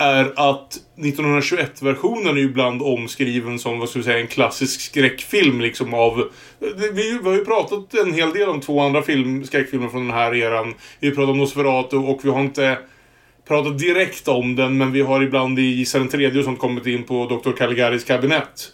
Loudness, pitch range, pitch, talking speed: -19 LUFS, 125-145 Hz, 135 Hz, 195 wpm